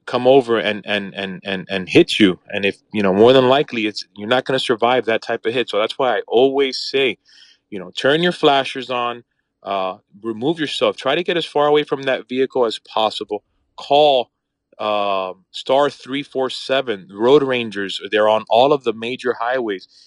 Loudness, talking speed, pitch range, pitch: -18 LUFS, 195 wpm, 105-135 Hz, 120 Hz